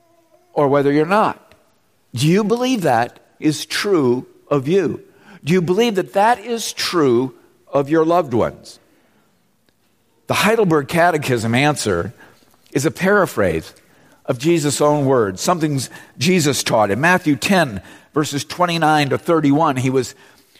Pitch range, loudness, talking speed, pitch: 140-185 Hz, -17 LUFS, 135 wpm, 155 Hz